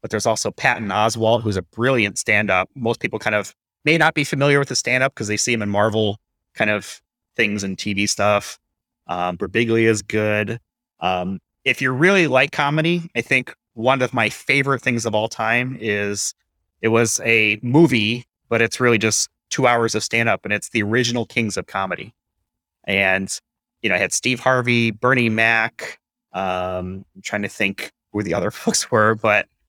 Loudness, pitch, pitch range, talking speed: -19 LUFS, 115 Hz, 105-125 Hz, 185 wpm